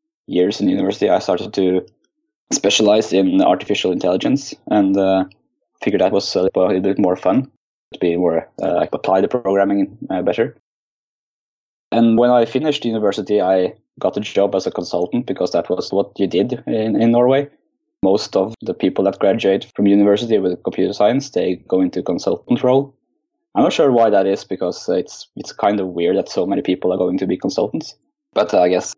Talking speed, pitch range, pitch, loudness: 195 wpm, 95-120 Hz, 100 Hz, -17 LUFS